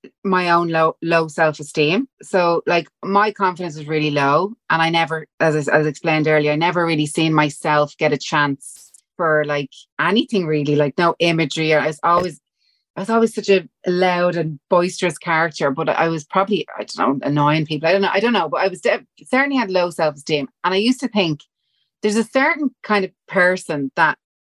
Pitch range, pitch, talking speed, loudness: 150-190 Hz, 165 Hz, 200 wpm, -18 LUFS